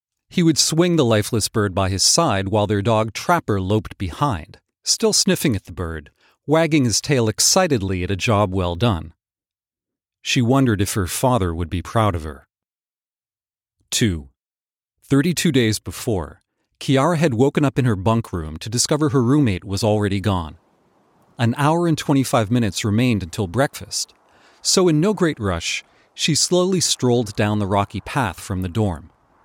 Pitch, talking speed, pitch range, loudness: 110 Hz, 165 wpm, 100-140 Hz, -19 LUFS